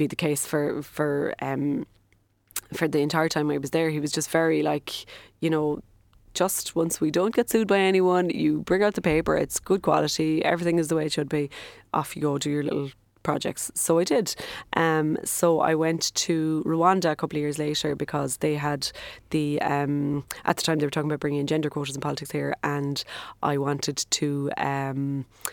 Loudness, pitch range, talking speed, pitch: -25 LUFS, 145-160 Hz, 205 wpm, 150 Hz